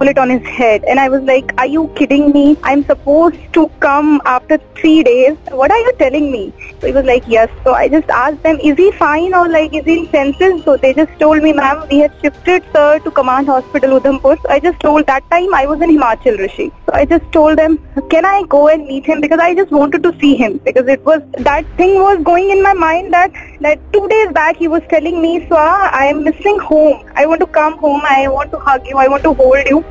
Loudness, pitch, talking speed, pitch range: -11 LUFS, 305 Hz, 250 wpm, 275-335 Hz